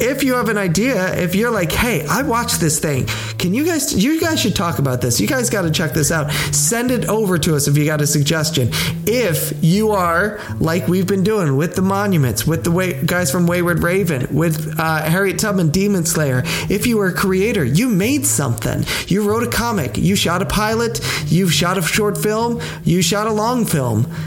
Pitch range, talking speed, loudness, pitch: 155-205 Hz, 220 wpm, -17 LUFS, 175 Hz